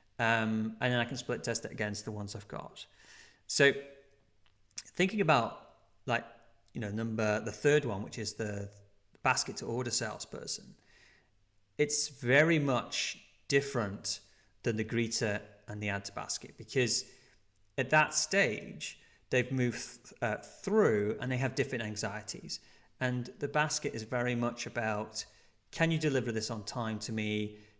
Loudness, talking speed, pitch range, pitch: -33 LUFS, 155 wpm, 105-130 Hz, 115 Hz